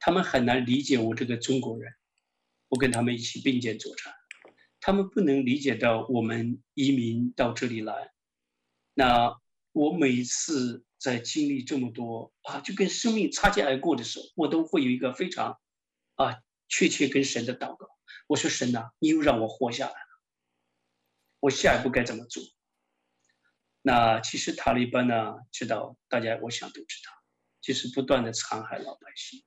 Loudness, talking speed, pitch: -27 LUFS, 250 characters per minute, 120 Hz